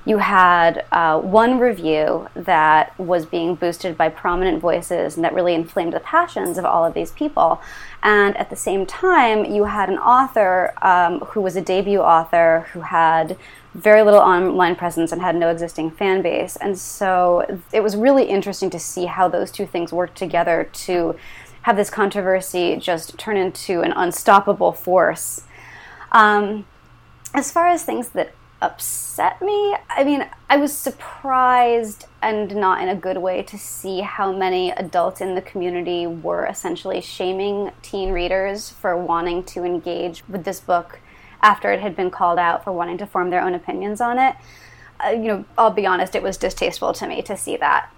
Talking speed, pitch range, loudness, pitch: 180 wpm, 175-210 Hz, -19 LUFS, 185 Hz